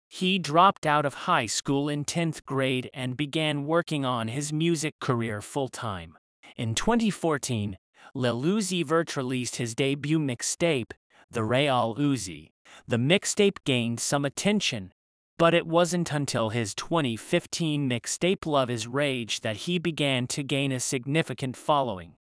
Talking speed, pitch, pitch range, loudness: 145 wpm, 140 Hz, 120-165 Hz, -27 LUFS